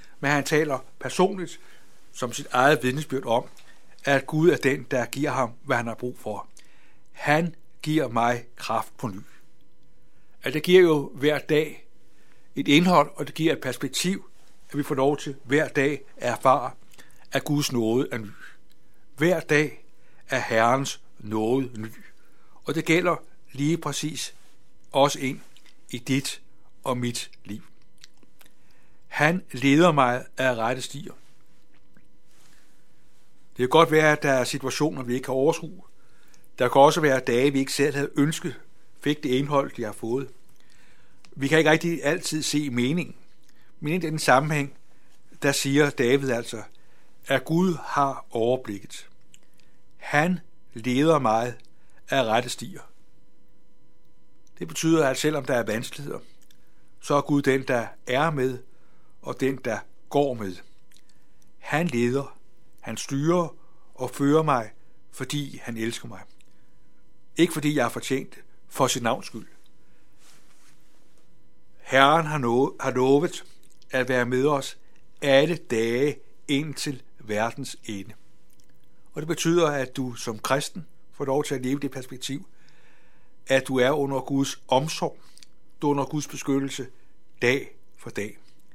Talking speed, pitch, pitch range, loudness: 140 wpm, 140 Hz, 130-150 Hz, -24 LUFS